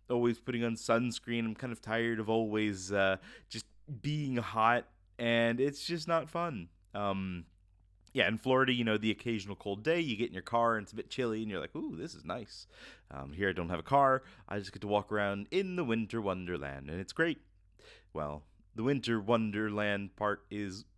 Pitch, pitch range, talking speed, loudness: 110 Hz, 95-120 Hz, 205 wpm, -34 LUFS